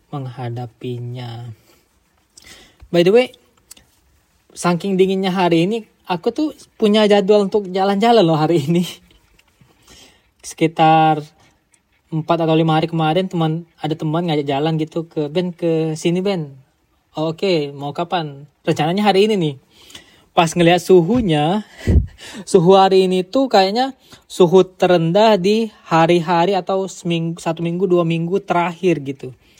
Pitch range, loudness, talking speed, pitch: 160-190 Hz, -17 LUFS, 130 wpm, 175 Hz